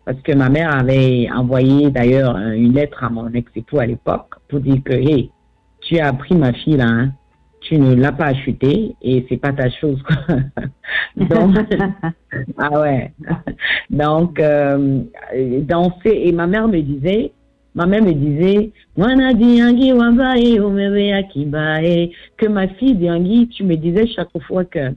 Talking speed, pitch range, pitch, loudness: 155 wpm, 130-190 Hz, 150 Hz, -16 LUFS